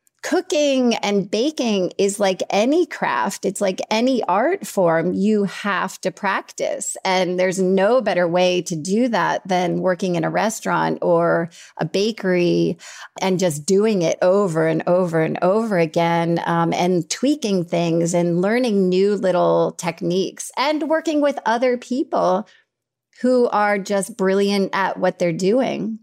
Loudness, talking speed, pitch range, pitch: -19 LUFS, 150 wpm, 175-215 Hz, 190 Hz